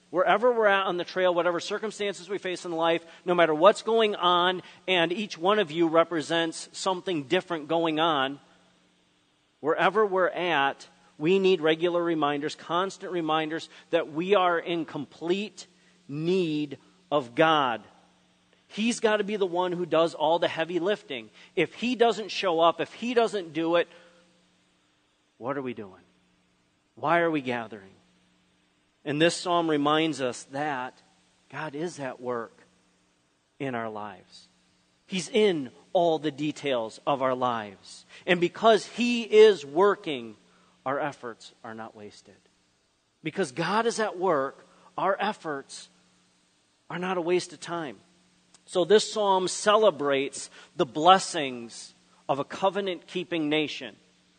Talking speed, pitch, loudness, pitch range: 140 wpm, 165 Hz, -26 LUFS, 135-185 Hz